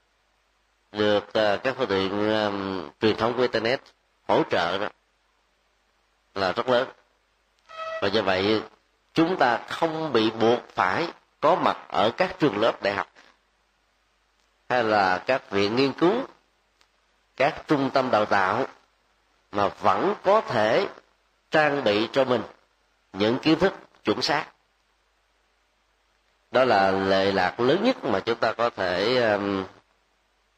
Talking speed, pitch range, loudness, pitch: 135 wpm, 100-135 Hz, -24 LUFS, 110 Hz